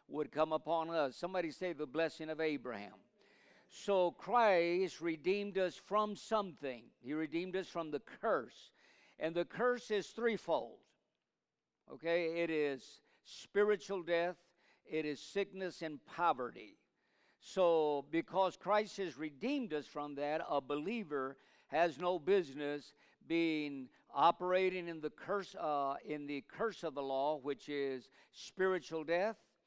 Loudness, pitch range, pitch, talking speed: -38 LUFS, 150-190 Hz, 165 Hz, 135 wpm